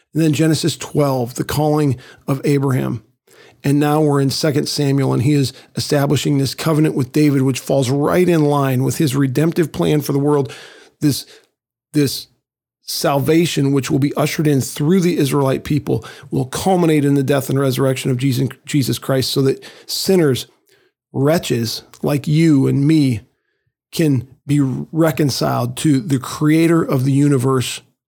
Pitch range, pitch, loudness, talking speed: 135-155 Hz, 140 Hz, -17 LUFS, 155 wpm